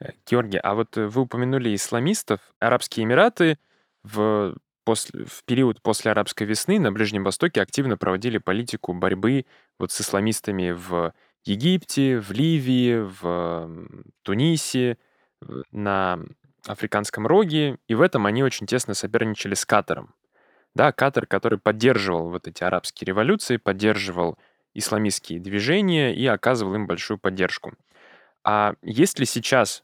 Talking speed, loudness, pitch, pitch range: 125 wpm, -23 LUFS, 110 Hz, 95-125 Hz